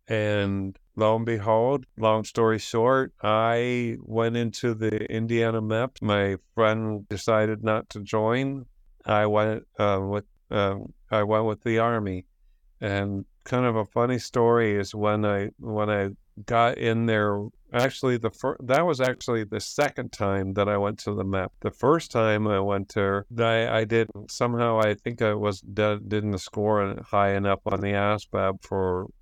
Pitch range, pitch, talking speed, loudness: 100-115 Hz, 110 Hz, 165 wpm, -25 LUFS